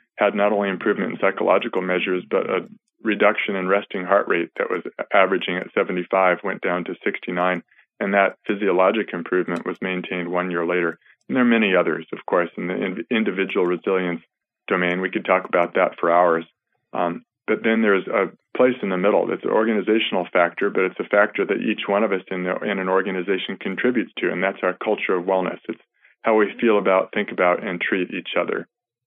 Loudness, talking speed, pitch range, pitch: -21 LUFS, 200 wpm, 90-95 Hz, 90 Hz